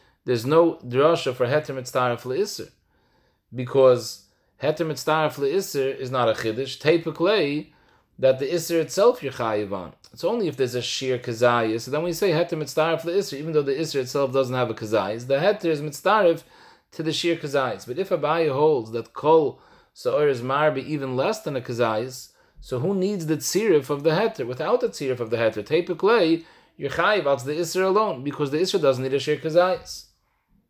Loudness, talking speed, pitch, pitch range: -23 LUFS, 185 wpm, 145 Hz, 130-165 Hz